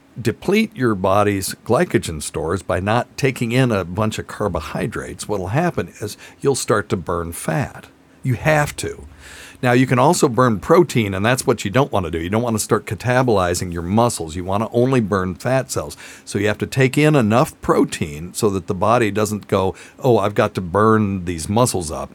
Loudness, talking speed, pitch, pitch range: -19 LUFS, 205 wpm, 110 Hz, 95-125 Hz